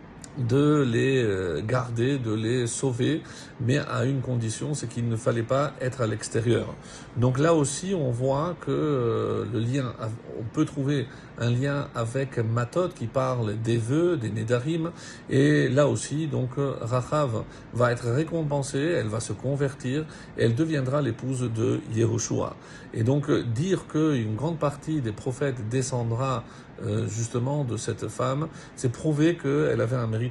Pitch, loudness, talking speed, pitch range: 130 Hz, -26 LUFS, 150 wpm, 115-145 Hz